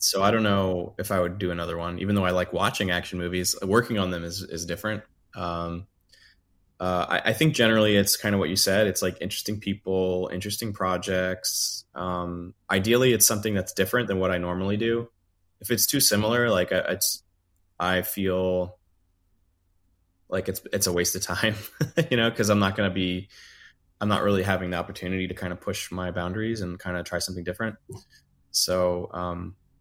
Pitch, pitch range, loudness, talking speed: 90 Hz, 90-105 Hz, -25 LUFS, 190 wpm